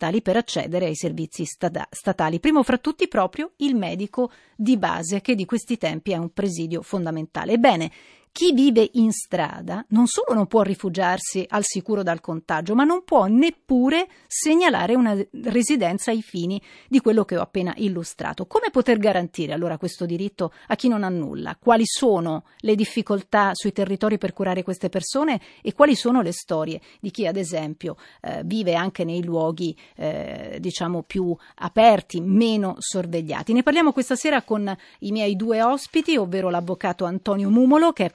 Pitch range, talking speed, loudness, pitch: 175-240 Hz, 165 wpm, -22 LUFS, 200 Hz